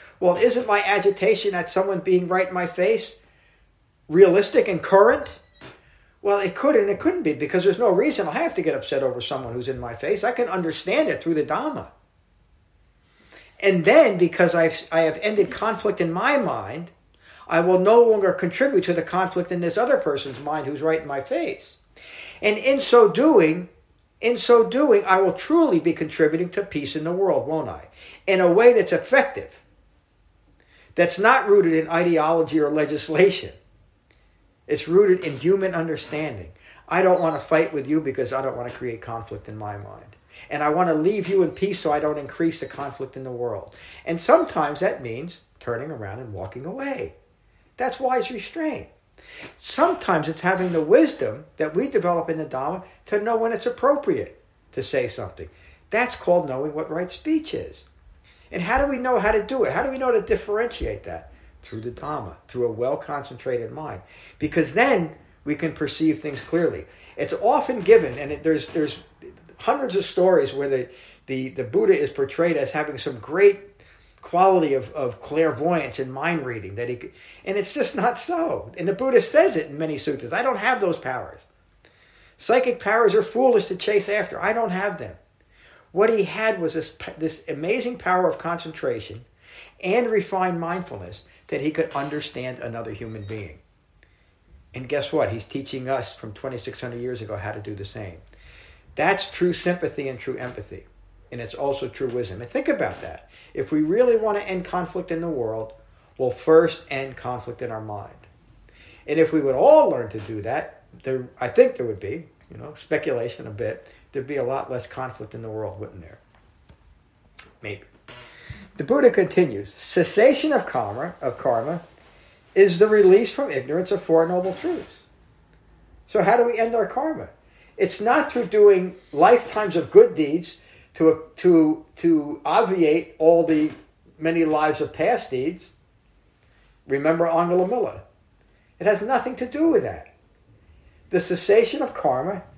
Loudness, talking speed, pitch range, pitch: -22 LUFS, 180 wpm, 135-230 Hz, 170 Hz